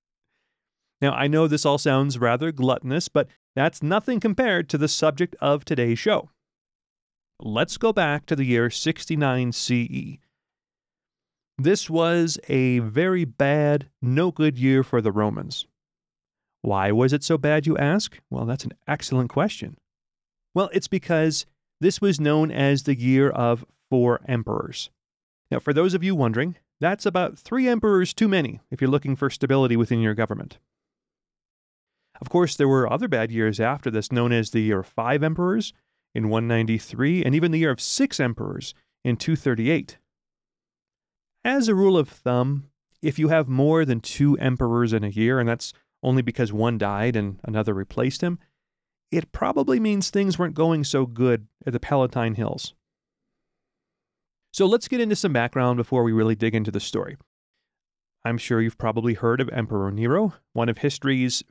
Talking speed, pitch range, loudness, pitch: 165 wpm, 120-160 Hz, -23 LUFS, 135 Hz